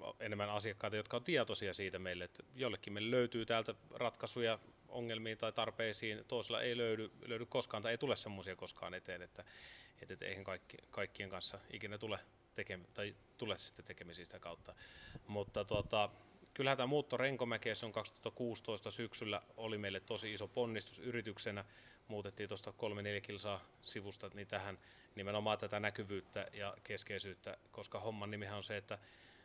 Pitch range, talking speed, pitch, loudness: 100-115 Hz, 155 wpm, 105 Hz, -43 LUFS